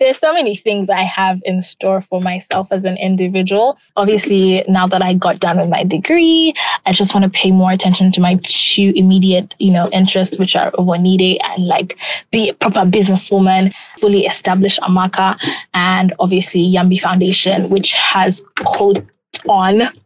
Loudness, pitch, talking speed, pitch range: -13 LUFS, 190 Hz, 165 wpm, 185-200 Hz